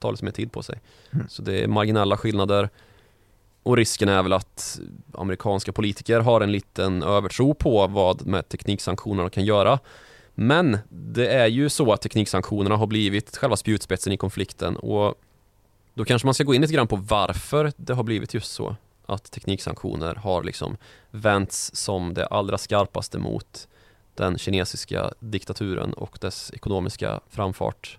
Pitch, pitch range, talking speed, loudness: 105 Hz, 100-120 Hz, 160 wpm, -24 LUFS